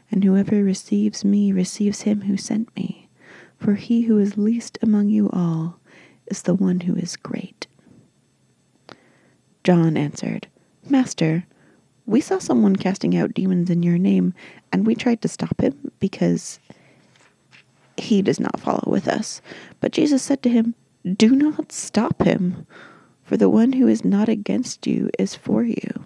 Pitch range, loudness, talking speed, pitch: 185-230 Hz, -20 LUFS, 155 wpm, 205 Hz